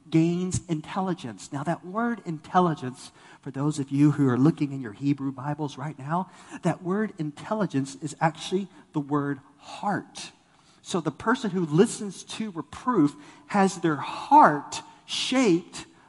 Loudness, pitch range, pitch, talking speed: -26 LUFS, 145-195 Hz, 160 Hz, 140 wpm